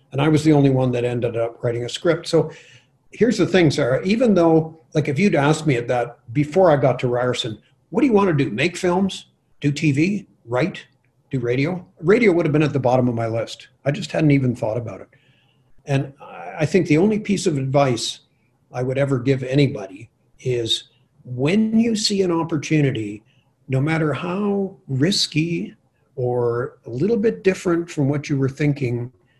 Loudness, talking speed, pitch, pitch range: -20 LUFS, 190 wpm, 140 Hz, 130-170 Hz